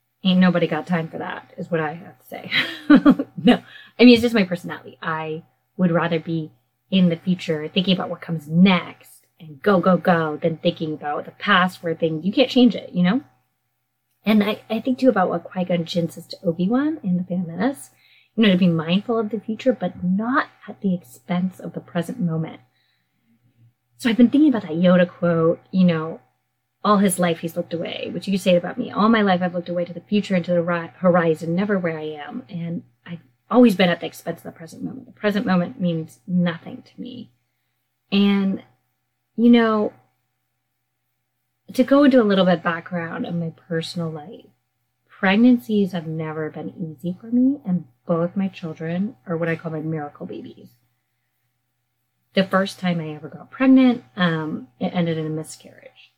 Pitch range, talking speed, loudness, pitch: 160-200 Hz, 200 wpm, -20 LUFS, 175 Hz